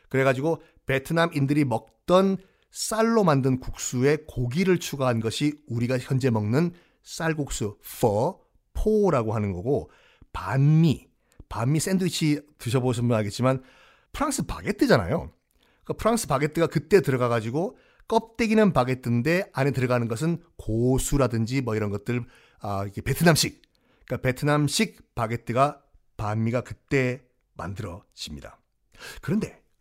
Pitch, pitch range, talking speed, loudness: 135 Hz, 120-160 Hz, 315 characters per minute, -25 LUFS